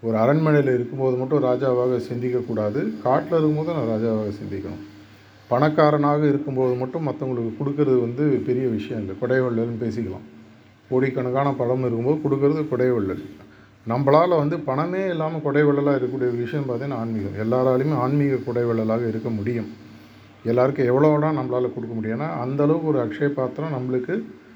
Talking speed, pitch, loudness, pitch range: 125 wpm, 125 Hz, -22 LUFS, 110-145 Hz